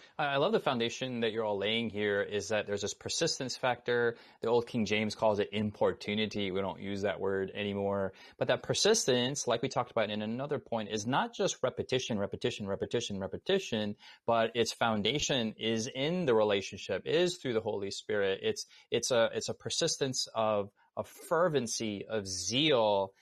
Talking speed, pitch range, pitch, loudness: 175 wpm, 105-140 Hz, 115 Hz, -32 LUFS